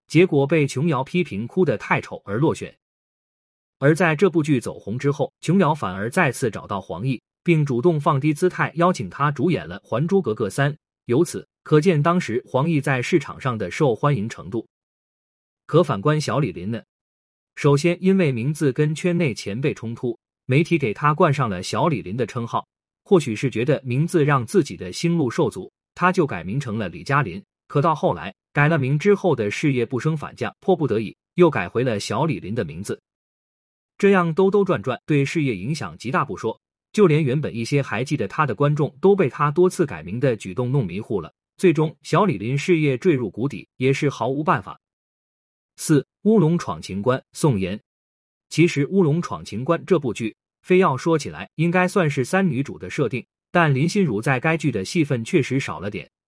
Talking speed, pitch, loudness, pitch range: 280 characters per minute, 150 Hz, -21 LUFS, 130-175 Hz